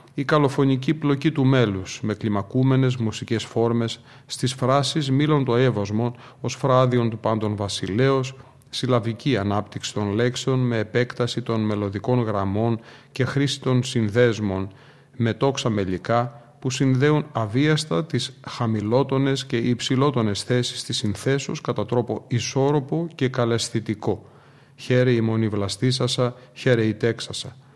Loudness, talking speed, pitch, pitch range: -23 LUFS, 120 wpm, 125 Hz, 115-135 Hz